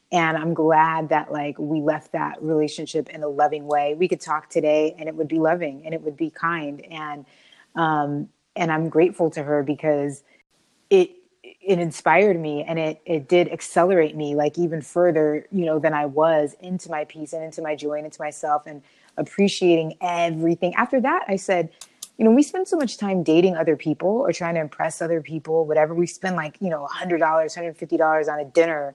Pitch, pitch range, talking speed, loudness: 160 Hz, 150-175 Hz, 200 wpm, -22 LUFS